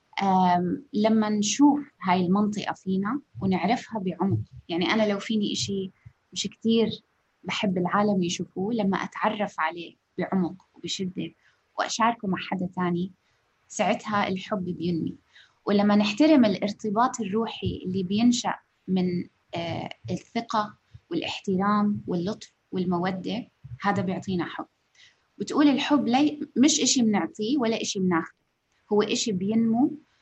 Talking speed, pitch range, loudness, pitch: 115 wpm, 185-225 Hz, -26 LUFS, 205 Hz